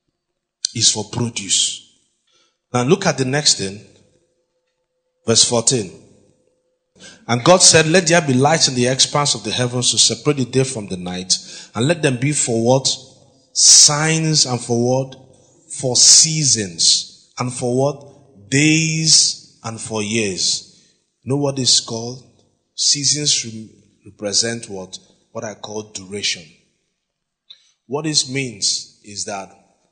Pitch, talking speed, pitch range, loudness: 130 Hz, 135 wpm, 110-150 Hz, -15 LUFS